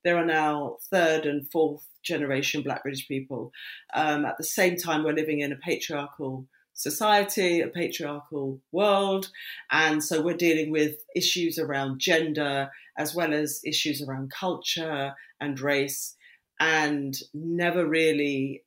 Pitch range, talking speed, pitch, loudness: 145-165 Hz, 140 wpm, 150 Hz, -26 LUFS